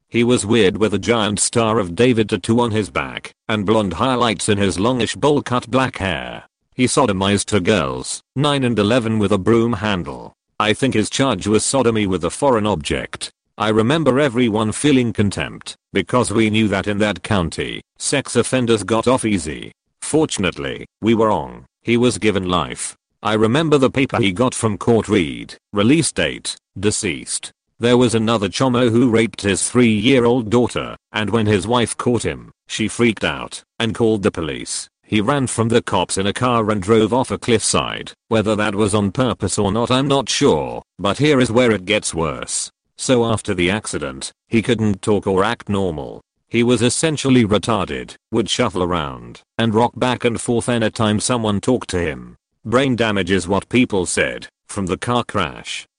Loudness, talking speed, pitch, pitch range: -18 LUFS, 185 wpm, 110 Hz, 100-120 Hz